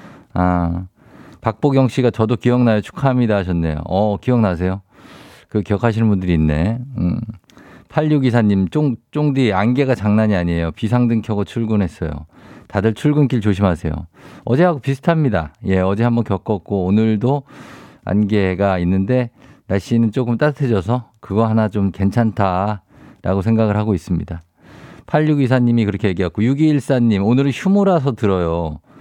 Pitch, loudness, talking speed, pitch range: 110 Hz, -17 LUFS, 305 characters per minute, 95-125 Hz